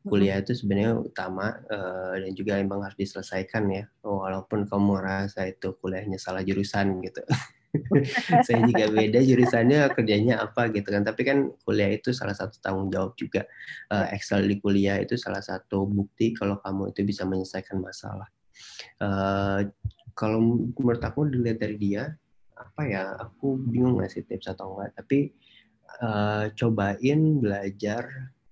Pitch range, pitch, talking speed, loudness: 95-115 Hz, 100 Hz, 145 wpm, -26 LUFS